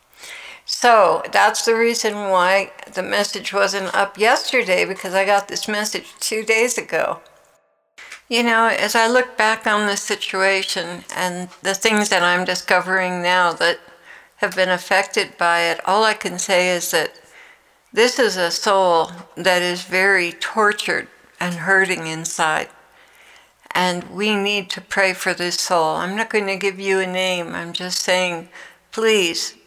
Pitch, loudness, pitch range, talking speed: 190 Hz, -18 LUFS, 180-210 Hz, 155 wpm